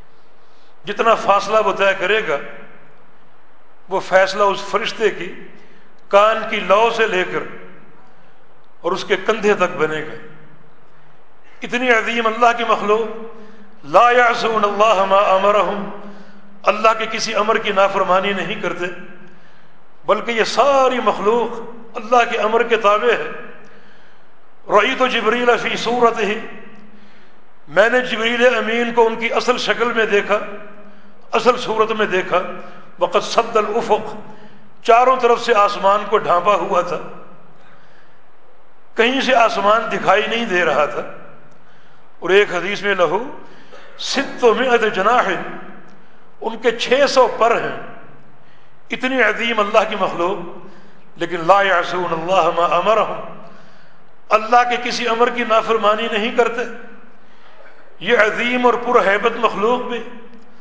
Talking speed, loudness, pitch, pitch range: 135 wpm, -16 LUFS, 215 Hz, 195-235 Hz